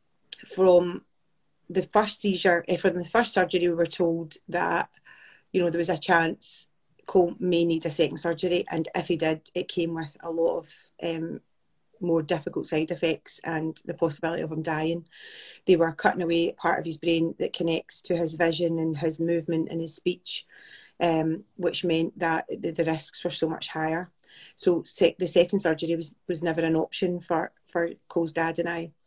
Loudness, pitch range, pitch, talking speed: -26 LUFS, 165-180 Hz, 170 Hz, 185 wpm